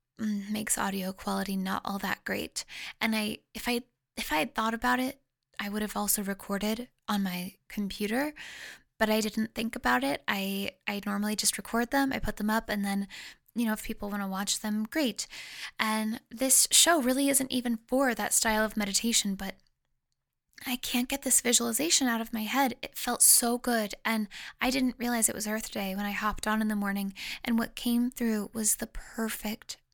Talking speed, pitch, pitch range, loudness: 200 wpm, 220 Hz, 205-245 Hz, -28 LUFS